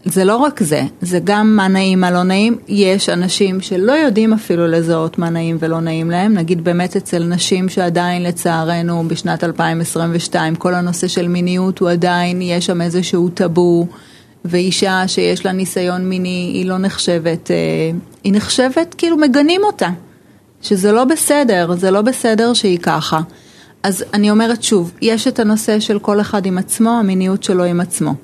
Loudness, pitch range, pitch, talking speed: -15 LUFS, 175-210 Hz, 185 Hz, 165 wpm